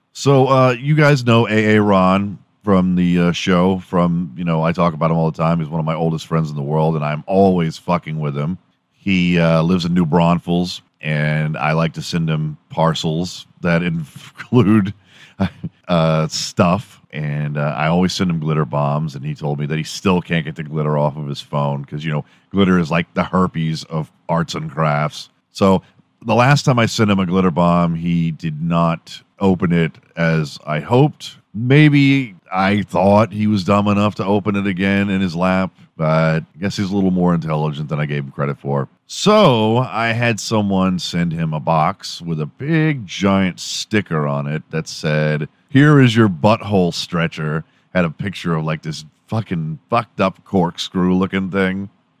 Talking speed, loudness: 195 wpm, -17 LUFS